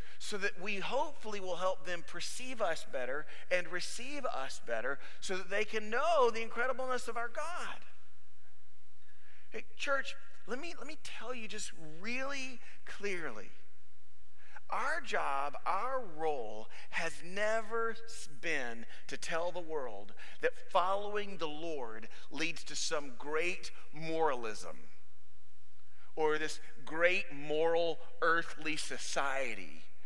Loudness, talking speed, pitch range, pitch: -37 LUFS, 120 wpm, 140-225 Hz, 175 Hz